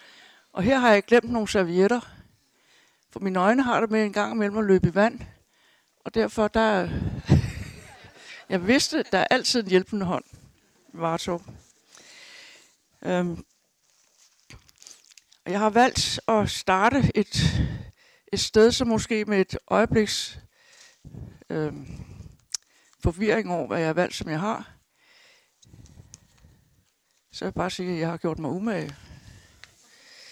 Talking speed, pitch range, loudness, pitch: 135 wpm, 185-240 Hz, -24 LUFS, 215 Hz